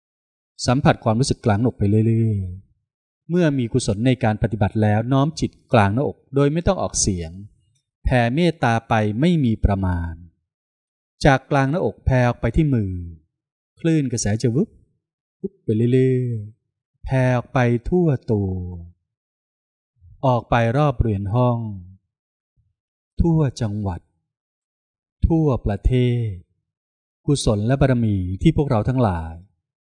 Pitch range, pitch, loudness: 100-130 Hz, 115 Hz, -20 LUFS